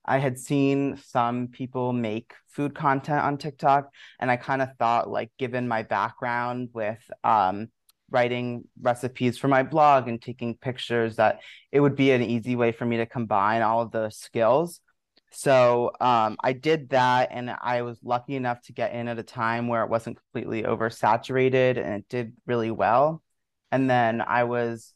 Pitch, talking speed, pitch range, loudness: 120 Hz, 180 wpm, 115-130 Hz, -25 LUFS